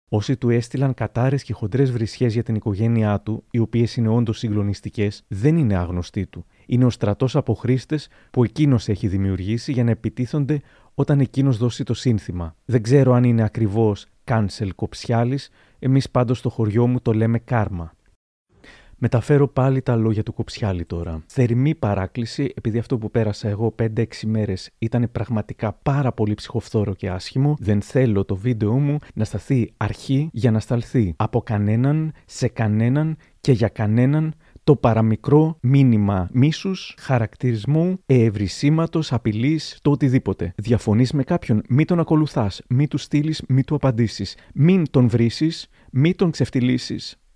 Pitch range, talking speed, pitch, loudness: 110-135 Hz, 155 wpm, 120 Hz, -21 LUFS